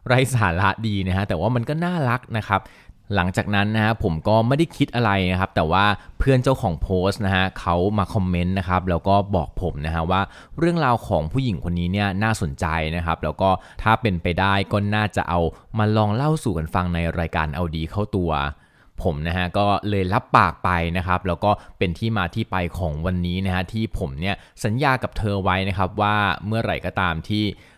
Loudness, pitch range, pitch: -22 LUFS, 90-110 Hz, 95 Hz